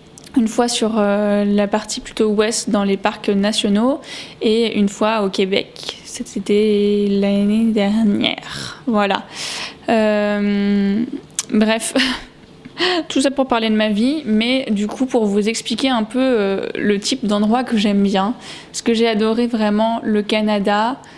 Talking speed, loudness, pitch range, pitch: 140 wpm, -17 LUFS, 205-240 Hz, 220 Hz